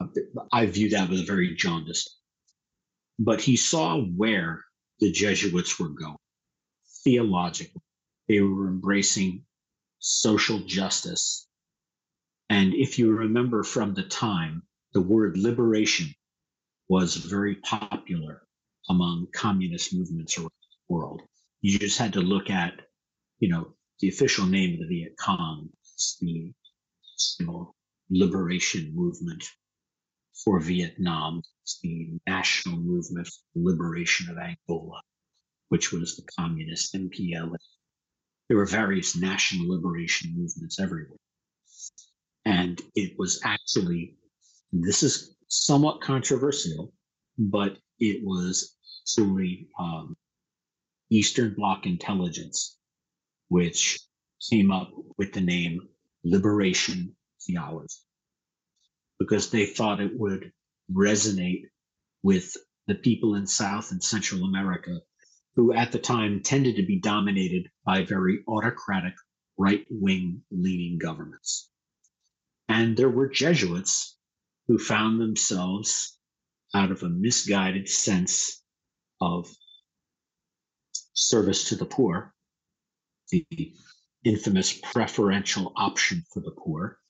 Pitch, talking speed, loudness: 105 Hz, 105 wpm, -26 LUFS